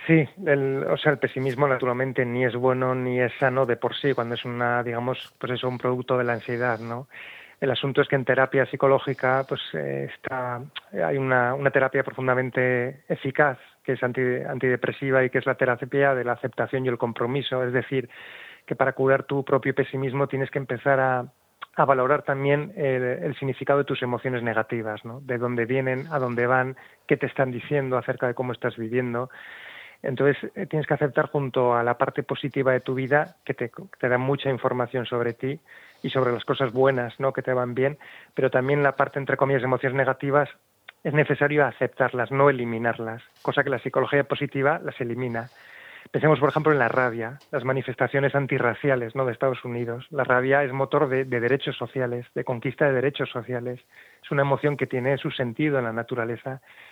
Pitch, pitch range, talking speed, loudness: 130 Hz, 125-140 Hz, 195 wpm, -25 LUFS